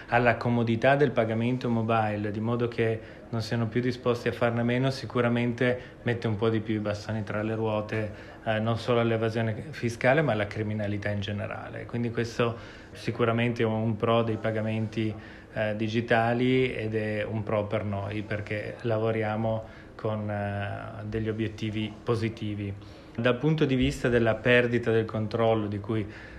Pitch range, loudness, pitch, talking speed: 110-120 Hz, -28 LUFS, 110 Hz, 155 wpm